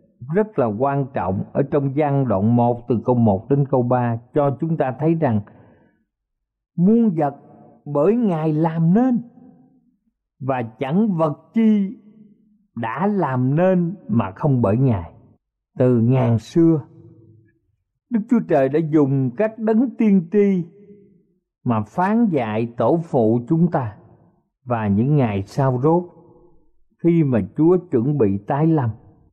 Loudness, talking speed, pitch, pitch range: -19 LUFS, 140 wpm, 150 Hz, 120-185 Hz